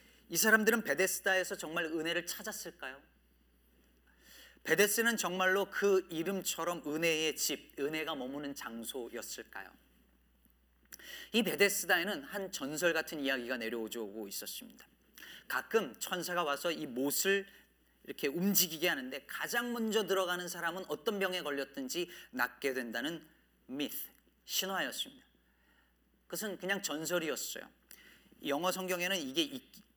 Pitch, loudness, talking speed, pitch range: 175 Hz, -34 LUFS, 295 characters per minute, 145-200 Hz